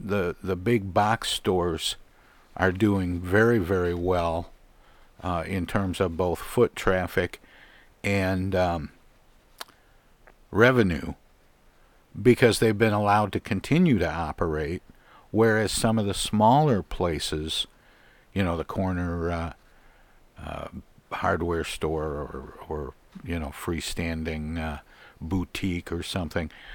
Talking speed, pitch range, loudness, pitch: 115 wpm, 85-105 Hz, -26 LUFS, 90 Hz